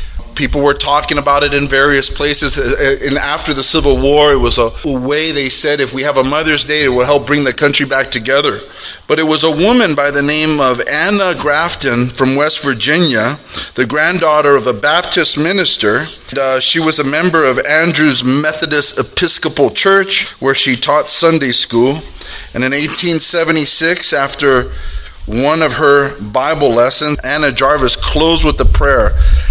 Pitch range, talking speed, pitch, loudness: 130-155 Hz, 170 wpm, 145 Hz, -10 LUFS